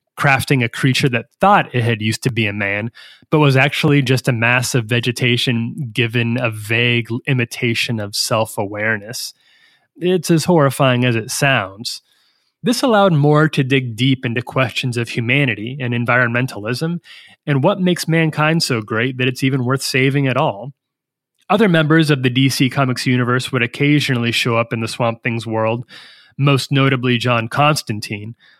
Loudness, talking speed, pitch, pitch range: -16 LUFS, 165 wpm, 130 Hz, 120-145 Hz